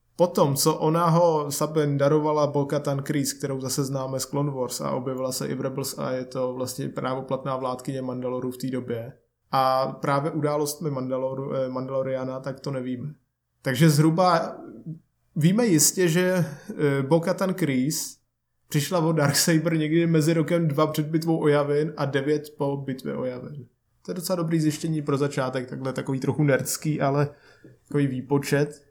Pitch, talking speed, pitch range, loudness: 145 Hz, 160 wpm, 130-155 Hz, -25 LUFS